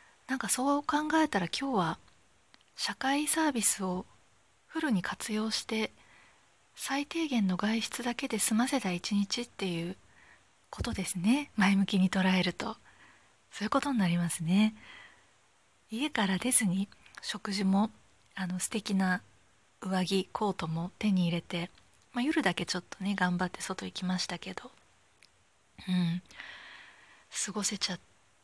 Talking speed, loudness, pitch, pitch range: 265 characters per minute, -31 LUFS, 205 Hz, 185-240 Hz